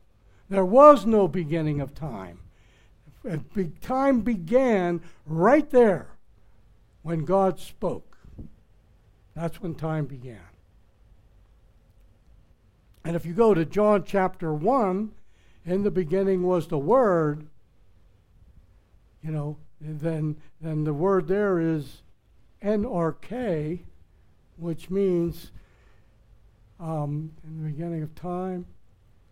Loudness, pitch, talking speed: -25 LUFS, 155 Hz, 105 wpm